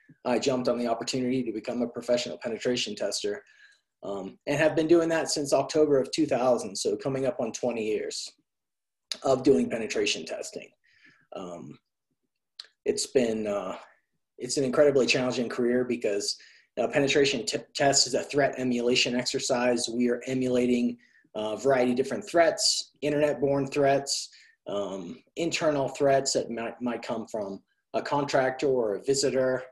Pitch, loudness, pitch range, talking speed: 130 Hz, -27 LUFS, 120-150 Hz, 150 wpm